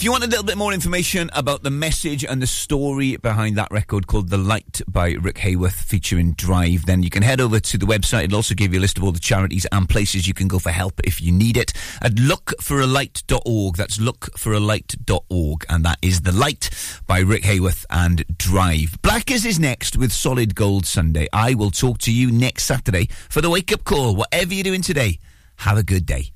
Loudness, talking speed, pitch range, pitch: -19 LUFS, 215 wpm, 90-130 Hz, 105 Hz